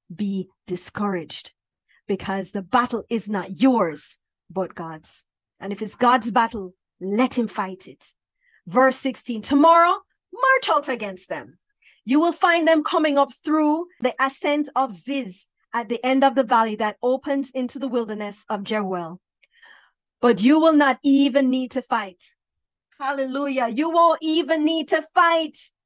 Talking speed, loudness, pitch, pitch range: 150 wpm, -21 LUFS, 255 Hz, 210-285 Hz